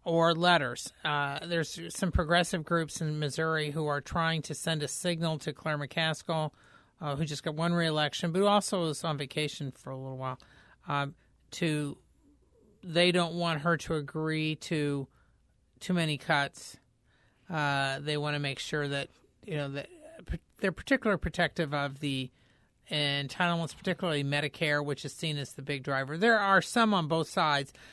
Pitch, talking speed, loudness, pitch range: 155 Hz, 165 wpm, -31 LUFS, 145-170 Hz